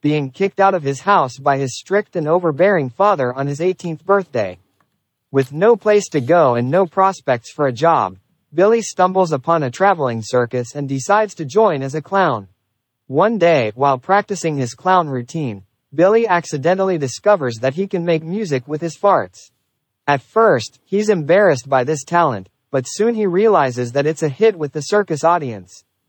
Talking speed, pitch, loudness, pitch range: 175 wpm, 155 Hz, -17 LUFS, 135-190 Hz